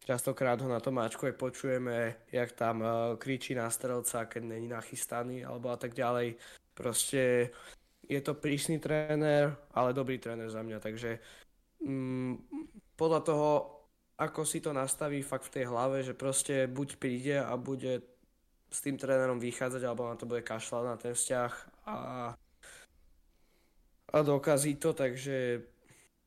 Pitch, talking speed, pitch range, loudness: 130 Hz, 145 wpm, 120-140 Hz, -34 LUFS